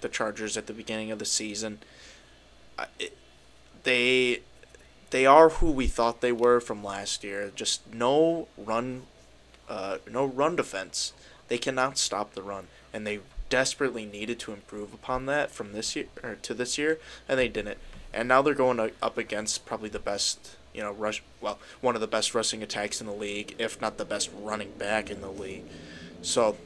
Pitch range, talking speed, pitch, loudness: 100-125 Hz, 180 wpm, 110 Hz, -28 LUFS